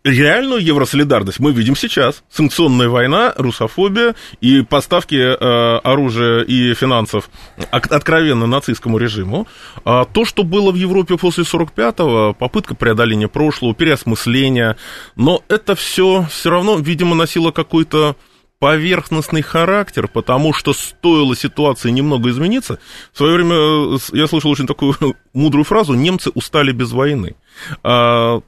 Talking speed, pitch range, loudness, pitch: 120 wpm, 120-165 Hz, -14 LUFS, 145 Hz